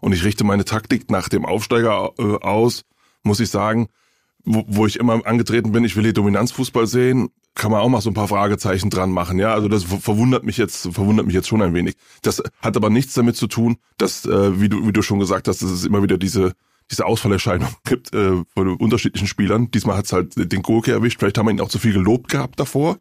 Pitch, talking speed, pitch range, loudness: 105 Hz, 230 wpm, 100-115 Hz, -19 LUFS